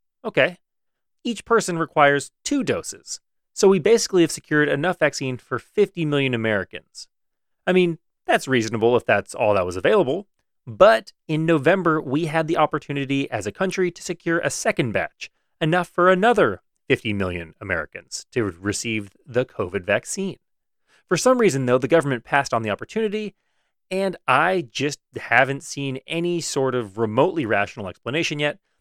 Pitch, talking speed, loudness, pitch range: 150 Hz, 155 wpm, -21 LUFS, 125-180 Hz